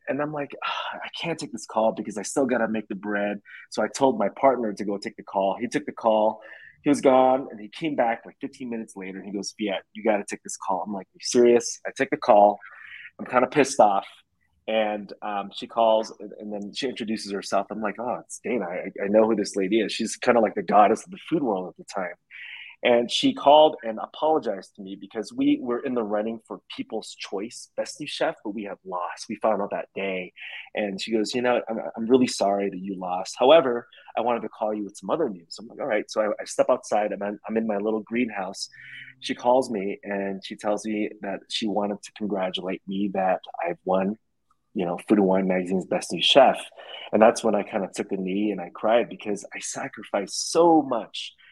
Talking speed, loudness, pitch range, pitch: 240 wpm, -25 LUFS, 100-120 Hz, 110 Hz